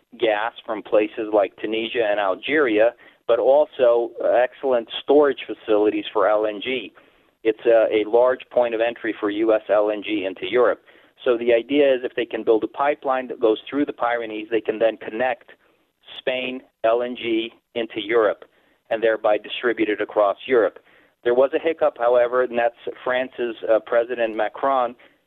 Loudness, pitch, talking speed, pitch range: -21 LUFS, 120 Hz, 155 wpm, 110-130 Hz